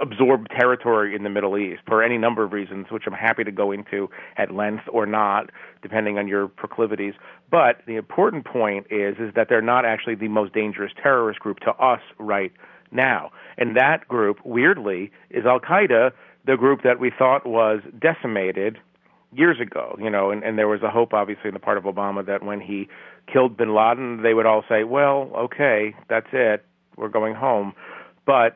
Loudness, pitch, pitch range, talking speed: -21 LUFS, 110 Hz, 100-115 Hz, 195 wpm